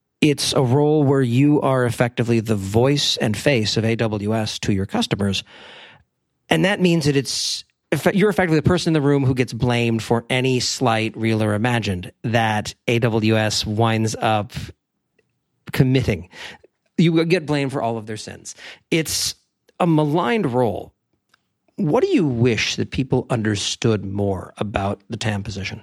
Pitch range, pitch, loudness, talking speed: 110-140 Hz, 120 Hz, -20 LUFS, 155 wpm